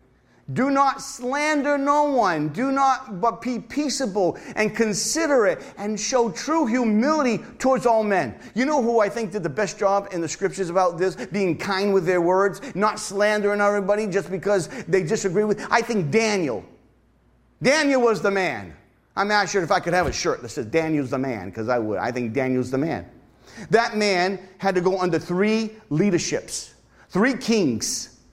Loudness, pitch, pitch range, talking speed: -22 LUFS, 205 Hz, 180-235 Hz, 180 wpm